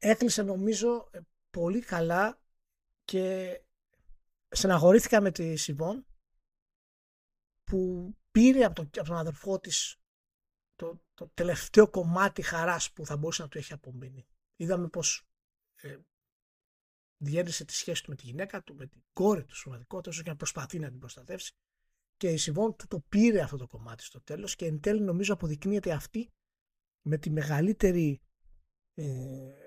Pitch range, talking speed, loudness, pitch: 145-195 Hz, 140 wpm, -29 LUFS, 170 Hz